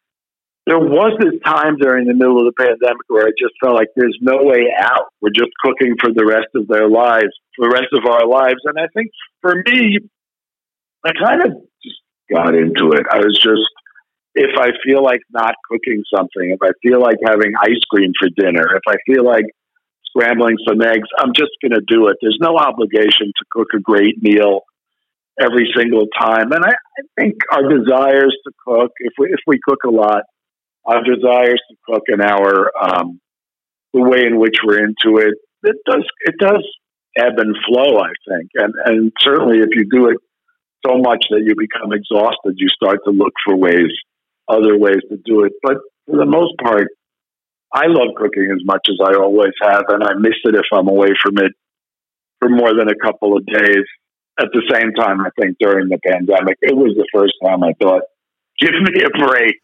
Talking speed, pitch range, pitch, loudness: 200 wpm, 105-125 Hz, 115 Hz, -13 LUFS